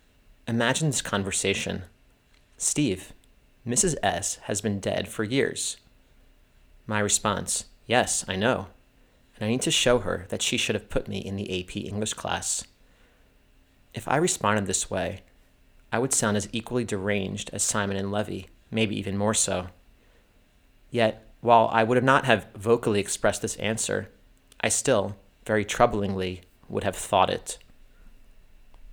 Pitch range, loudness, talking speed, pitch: 95-110 Hz, -26 LUFS, 145 wpm, 105 Hz